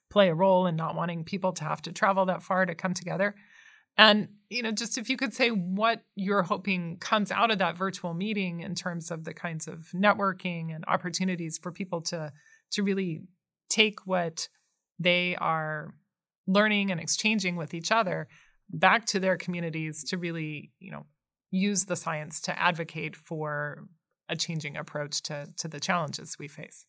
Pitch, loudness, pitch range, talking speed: 180 Hz, -28 LUFS, 165-200 Hz, 180 wpm